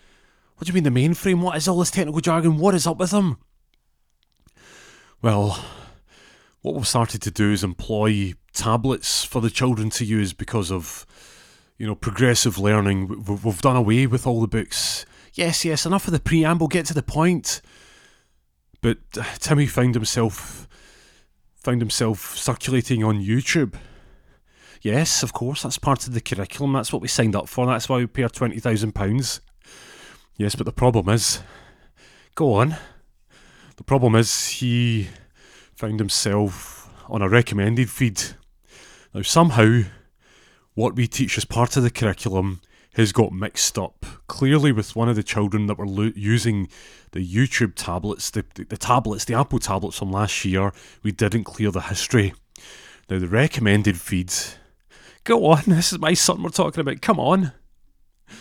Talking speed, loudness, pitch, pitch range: 165 wpm, -21 LUFS, 115 Hz, 100-130 Hz